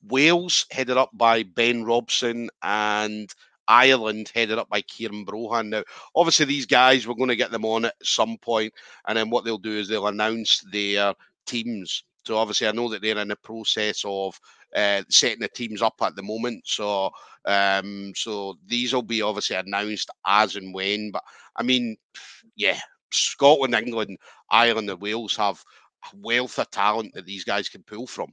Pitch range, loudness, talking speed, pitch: 105-120 Hz, -23 LUFS, 180 wpm, 110 Hz